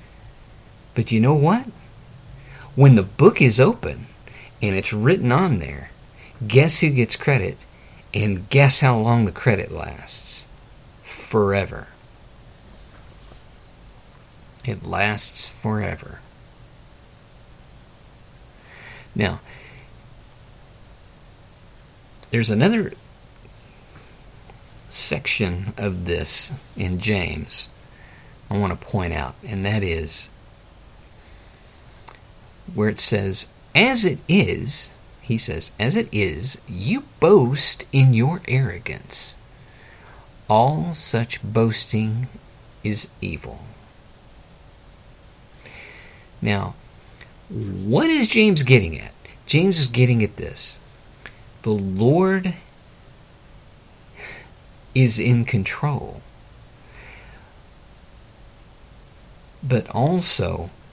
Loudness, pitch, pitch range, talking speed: -20 LUFS, 115 Hz, 105-135 Hz, 85 wpm